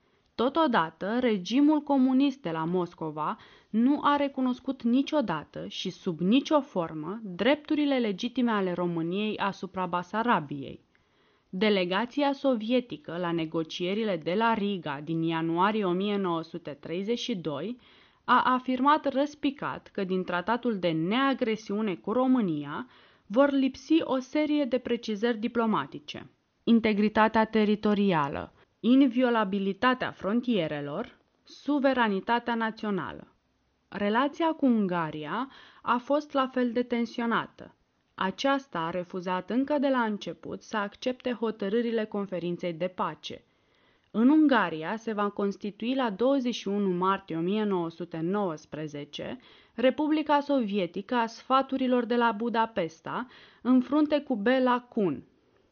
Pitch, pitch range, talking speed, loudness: 225 Hz, 185-255 Hz, 105 wpm, -28 LUFS